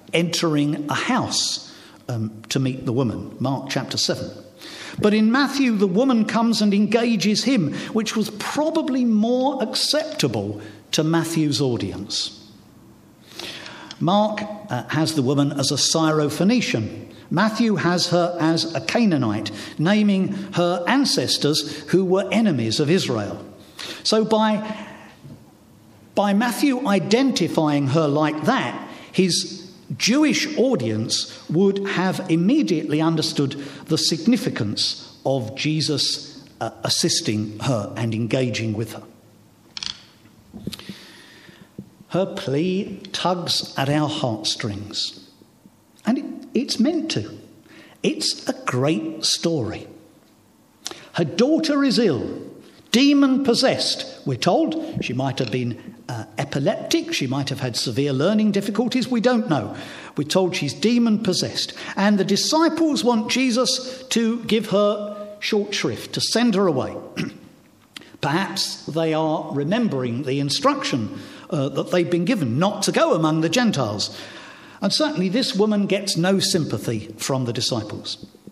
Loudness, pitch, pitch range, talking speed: -21 LUFS, 175 Hz, 135-220 Hz, 120 wpm